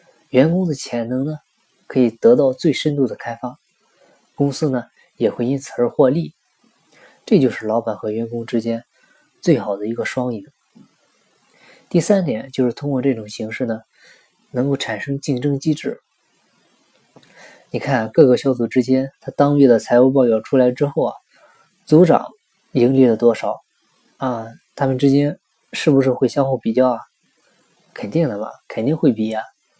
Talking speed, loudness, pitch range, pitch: 235 characters per minute, -18 LUFS, 120-140 Hz, 130 Hz